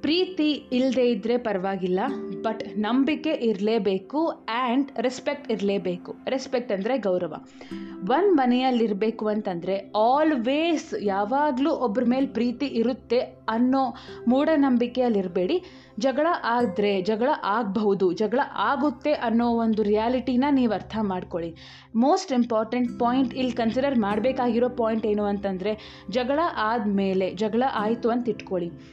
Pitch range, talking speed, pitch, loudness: 210-265 Hz, 105 wpm, 235 Hz, -24 LUFS